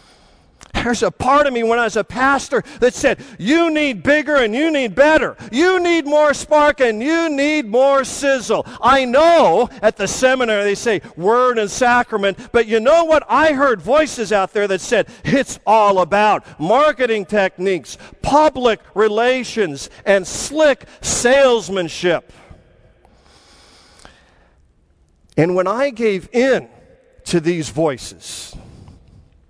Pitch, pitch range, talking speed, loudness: 240 Hz, 195-280 Hz, 135 wpm, -16 LUFS